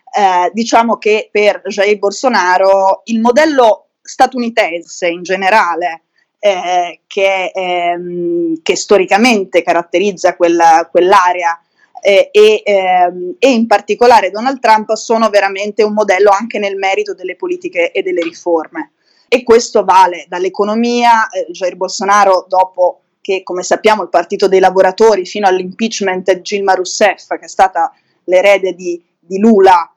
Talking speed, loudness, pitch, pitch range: 130 wpm, -11 LUFS, 195 Hz, 180-225 Hz